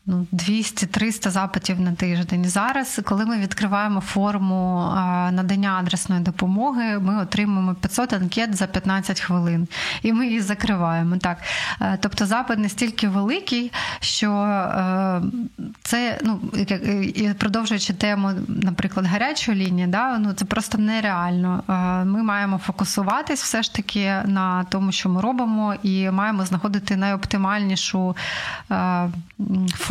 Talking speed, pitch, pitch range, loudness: 115 wpm, 200 Hz, 185-215 Hz, -22 LUFS